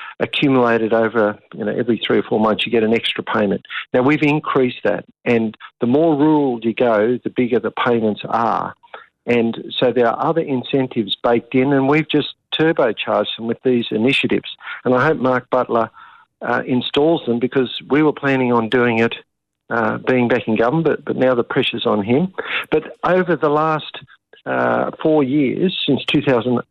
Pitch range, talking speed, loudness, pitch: 120-150 Hz, 180 wpm, -18 LUFS, 130 Hz